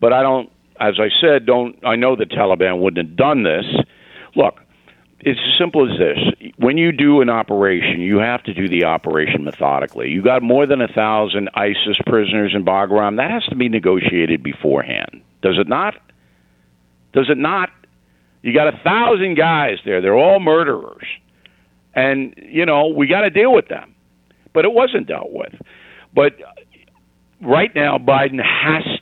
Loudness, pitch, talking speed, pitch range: -16 LUFS, 110 Hz, 170 wpm, 90-145 Hz